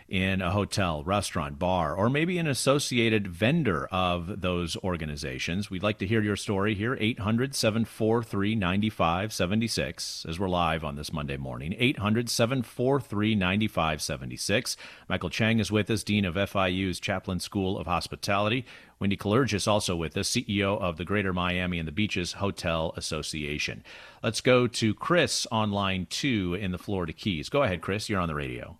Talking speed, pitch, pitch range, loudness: 165 wpm, 100 Hz, 90-110 Hz, -28 LUFS